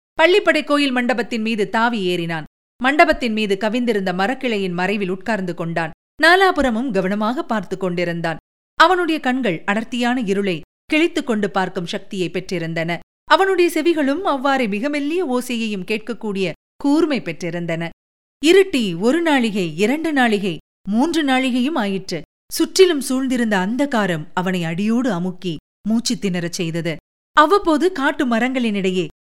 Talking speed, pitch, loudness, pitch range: 115 wpm, 225 Hz, -19 LUFS, 185-285 Hz